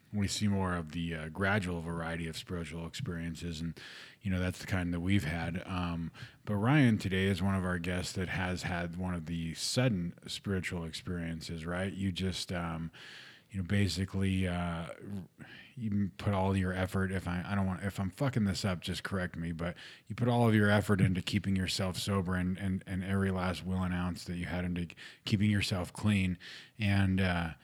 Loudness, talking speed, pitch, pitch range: -34 LUFS, 200 wpm, 95 Hz, 85-100 Hz